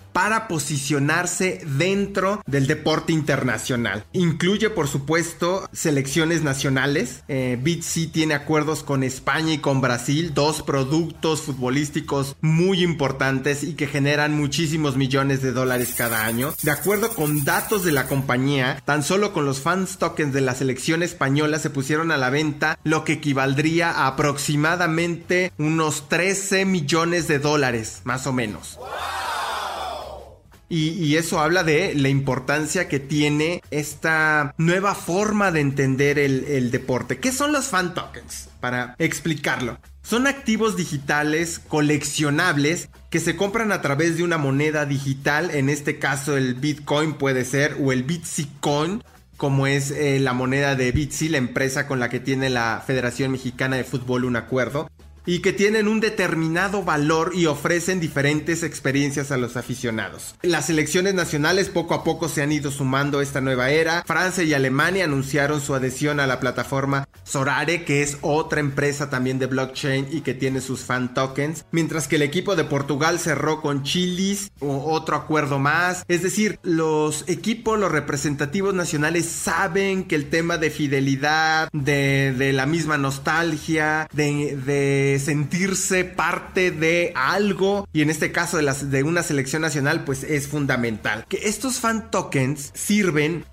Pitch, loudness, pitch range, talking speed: 150 Hz, -22 LUFS, 140-170 Hz, 155 wpm